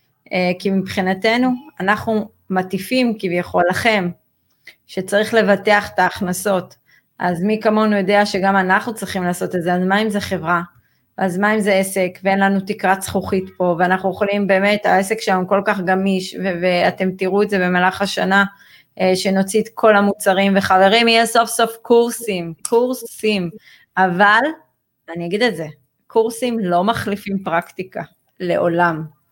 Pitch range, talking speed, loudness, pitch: 185-210 Hz, 145 wpm, -17 LUFS, 195 Hz